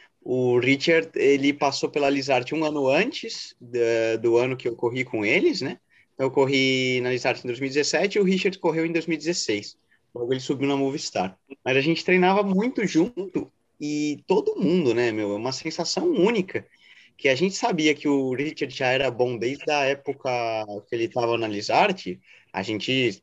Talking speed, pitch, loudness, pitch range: 180 wpm, 135 Hz, -24 LUFS, 125-160 Hz